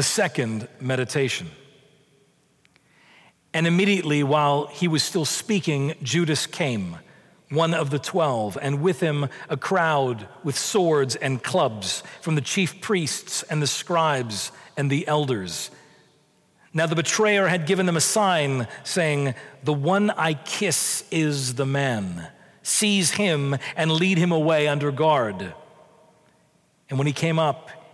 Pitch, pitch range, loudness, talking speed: 155 Hz, 140-170 Hz, -23 LUFS, 135 wpm